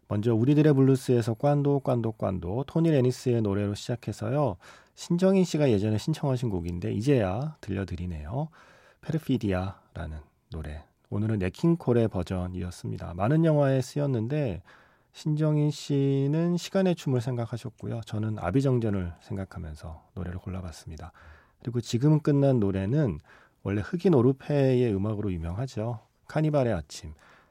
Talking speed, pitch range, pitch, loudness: 340 characters per minute, 95-145 Hz, 120 Hz, -27 LUFS